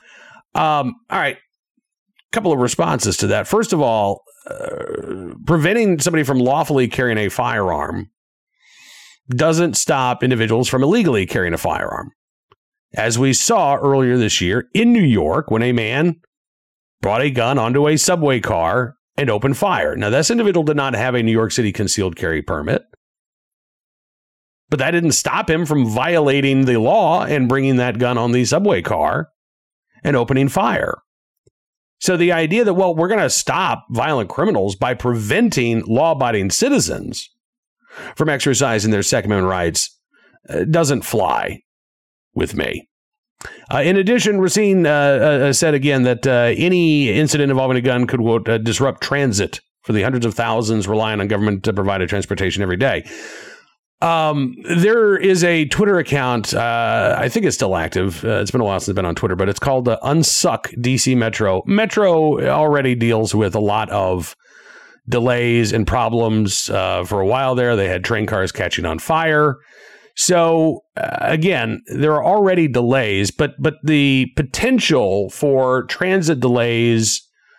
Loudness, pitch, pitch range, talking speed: -17 LUFS, 130 Hz, 110-160 Hz, 160 wpm